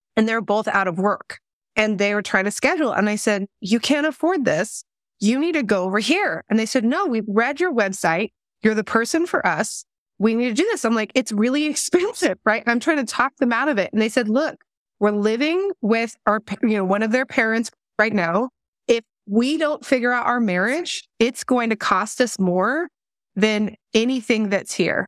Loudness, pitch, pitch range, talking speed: -21 LUFS, 230 Hz, 210-270 Hz, 220 wpm